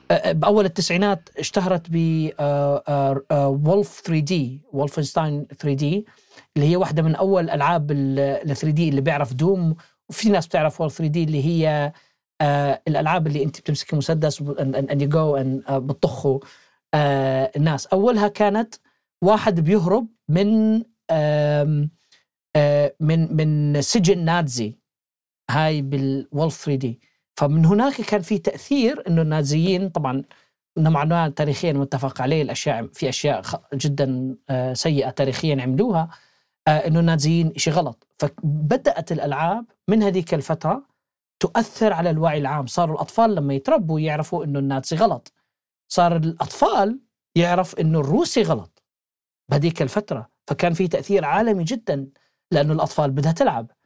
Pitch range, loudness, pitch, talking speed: 145-180 Hz, -21 LUFS, 155 Hz, 120 wpm